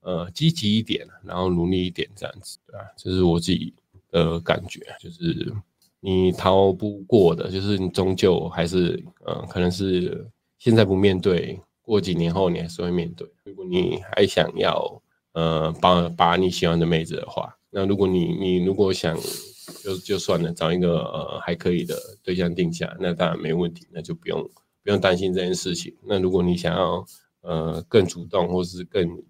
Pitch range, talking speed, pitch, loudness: 85-95 Hz, 265 characters per minute, 90 Hz, -23 LUFS